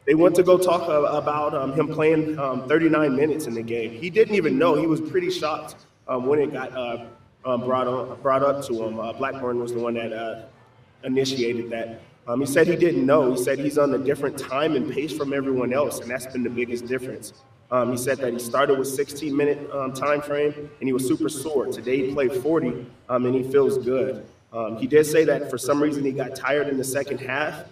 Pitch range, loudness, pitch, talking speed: 125-150 Hz, -23 LUFS, 135 Hz, 235 wpm